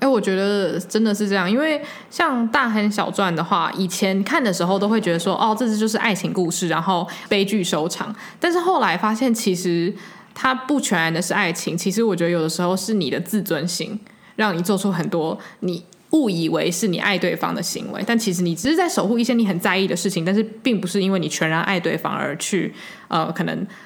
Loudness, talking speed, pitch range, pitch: -20 LUFS, 325 characters per minute, 180-220 Hz, 195 Hz